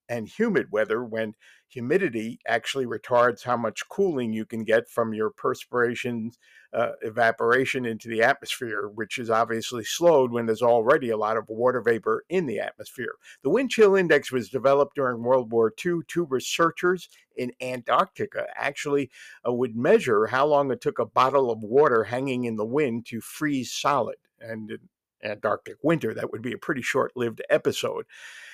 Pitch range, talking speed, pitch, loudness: 115-135 Hz, 170 wpm, 120 Hz, -25 LUFS